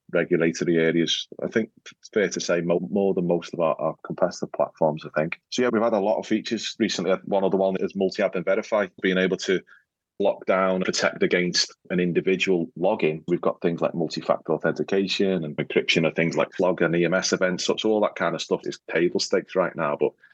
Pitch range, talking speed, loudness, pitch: 85-95 Hz, 220 wpm, -24 LUFS, 90 Hz